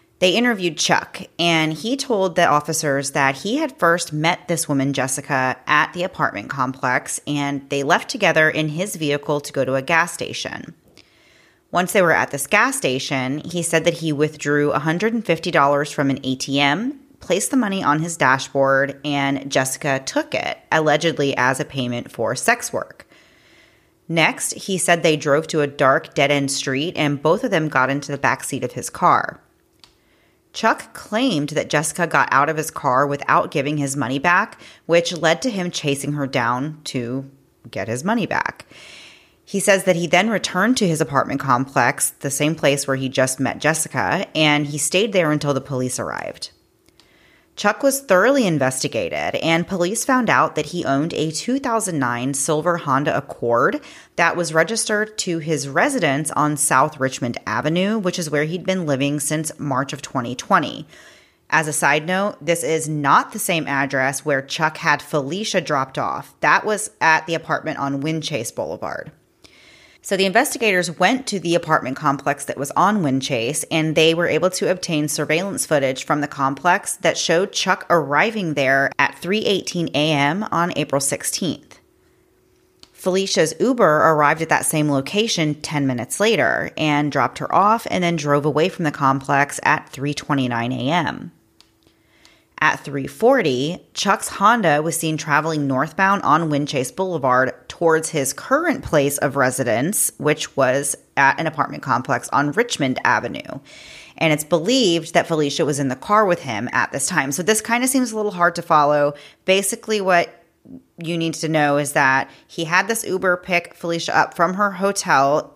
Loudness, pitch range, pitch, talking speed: -19 LUFS, 140-175 Hz, 155 Hz, 170 wpm